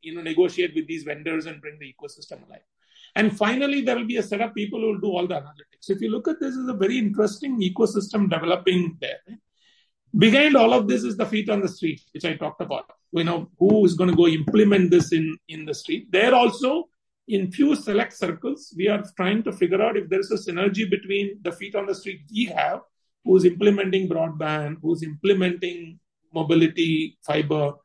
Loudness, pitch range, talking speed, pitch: -22 LUFS, 170-225 Hz, 215 wpm, 200 Hz